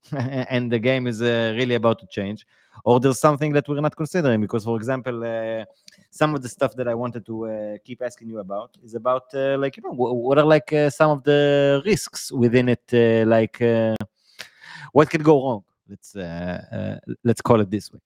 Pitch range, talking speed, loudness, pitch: 115-140 Hz, 215 wpm, -21 LUFS, 120 Hz